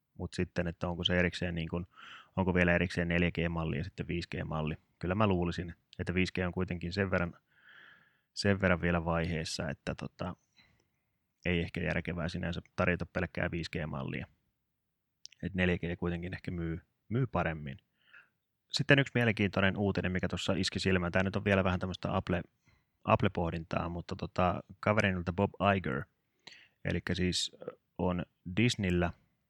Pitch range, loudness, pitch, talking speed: 85-95 Hz, -33 LUFS, 90 Hz, 140 wpm